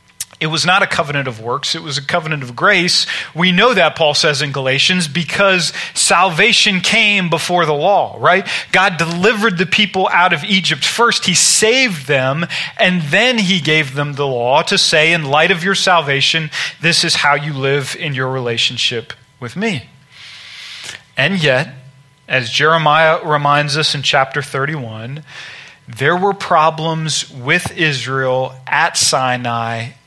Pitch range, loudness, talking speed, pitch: 140-180 Hz, -13 LUFS, 155 wpm, 155 Hz